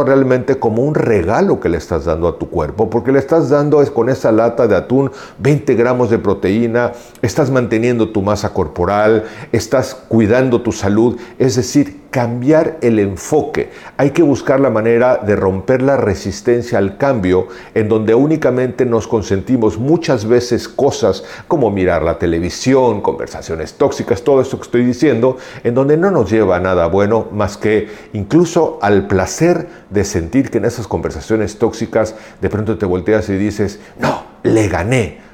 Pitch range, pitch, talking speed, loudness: 105-130 Hz, 115 Hz, 165 wpm, -14 LUFS